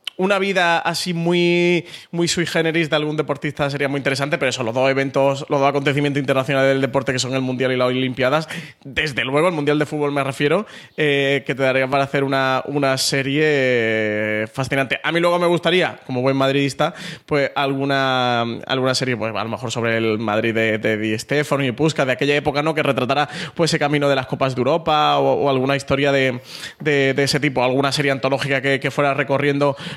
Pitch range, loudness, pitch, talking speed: 130-150 Hz, -19 LUFS, 140 Hz, 205 wpm